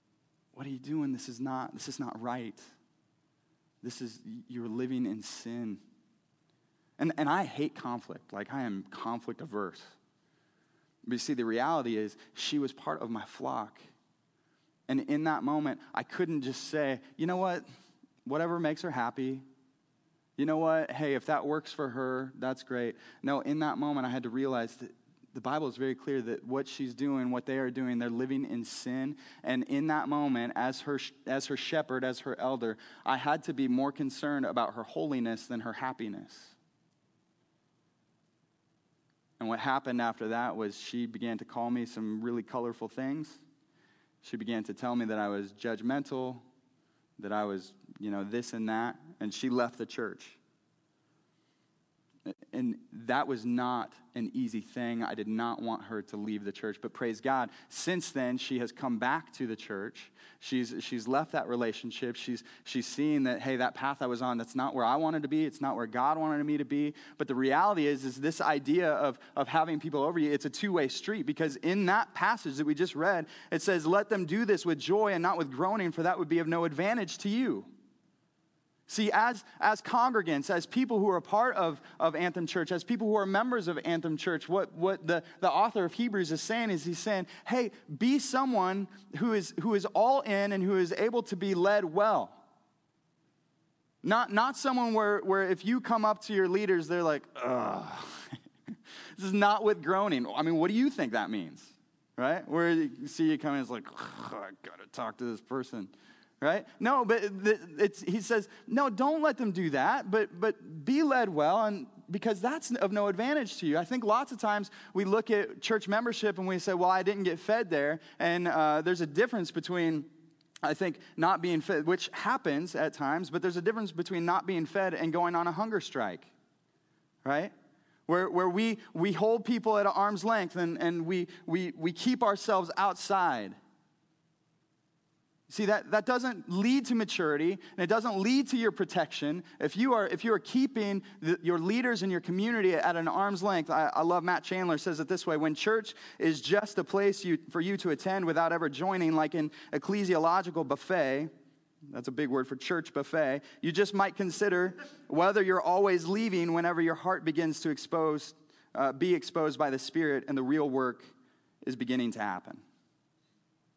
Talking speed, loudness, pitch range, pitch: 195 wpm, -32 LUFS, 135-195 Hz, 160 Hz